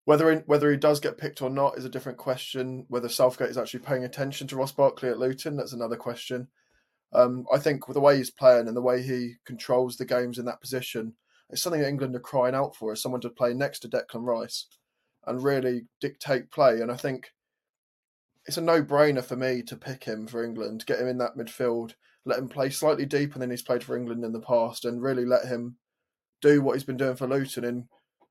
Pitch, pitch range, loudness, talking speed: 125 Hz, 120-135 Hz, -27 LUFS, 230 wpm